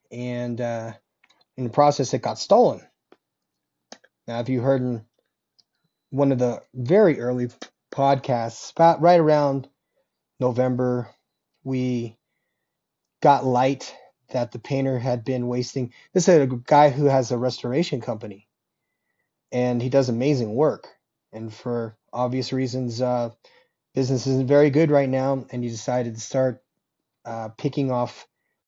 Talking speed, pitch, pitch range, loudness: 135 wpm, 125 Hz, 120-135 Hz, -22 LUFS